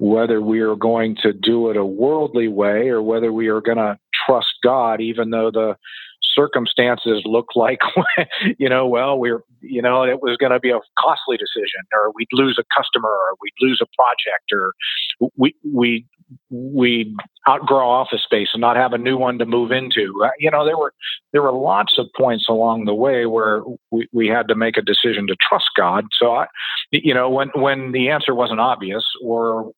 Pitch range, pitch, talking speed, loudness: 115-130 Hz, 120 Hz, 200 wpm, -17 LUFS